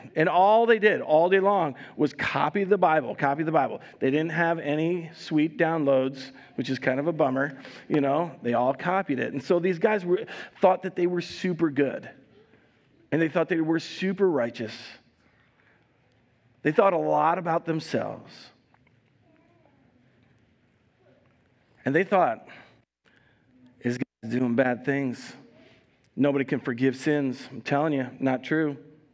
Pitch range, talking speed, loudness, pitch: 125-165 Hz, 150 wpm, -25 LUFS, 145 Hz